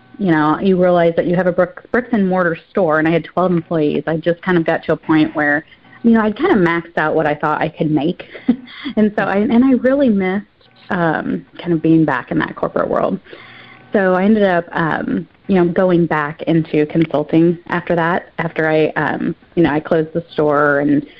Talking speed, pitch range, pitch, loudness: 225 wpm, 155-190 Hz, 170 Hz, -16 LUFS